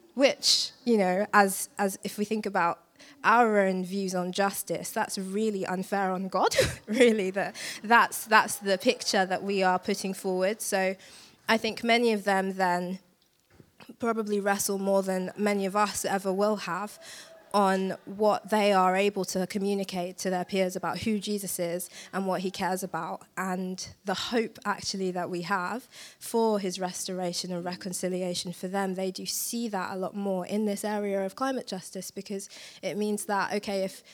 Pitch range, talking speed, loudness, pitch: 185-210 Hz, 175 wpm, -28 LUFS, 195 Hz